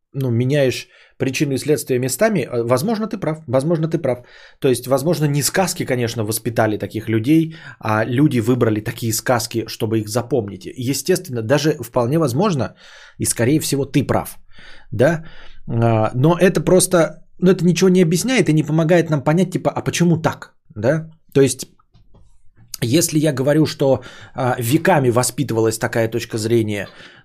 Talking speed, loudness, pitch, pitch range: 150 wpm, -18 LUFS, 135 Hz, 120-160 Hz